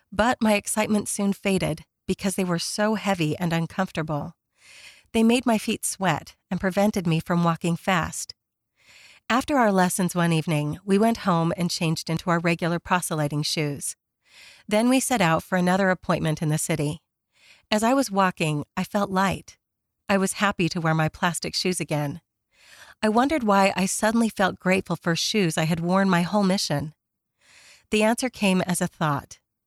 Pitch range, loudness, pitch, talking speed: 165-205 Hz, -24 LUFS, 185 Hz, 170 wpm